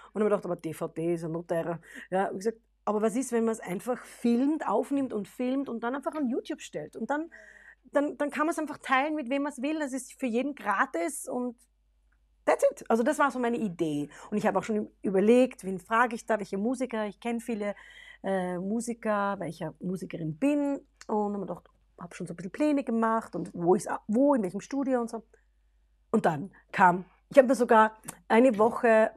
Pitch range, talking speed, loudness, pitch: 190-265 Hz, 220 wpm, -29 LUFS, 225 Hz